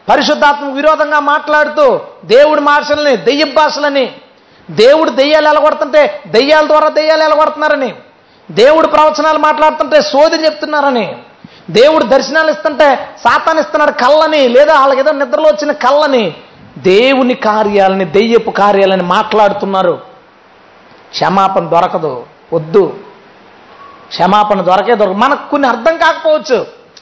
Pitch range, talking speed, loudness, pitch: 235-310 Hz, 100 wpm, -10 LUFS, 295 Hz